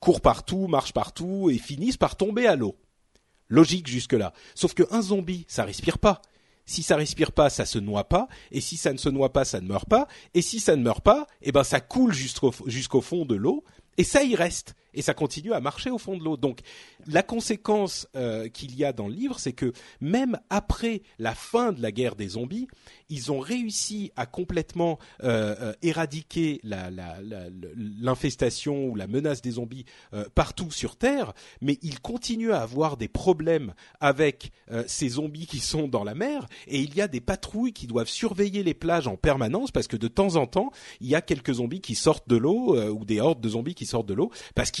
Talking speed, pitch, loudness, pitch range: 220 wpm, 150 Hz, -26 LUFS, 120-190 Hz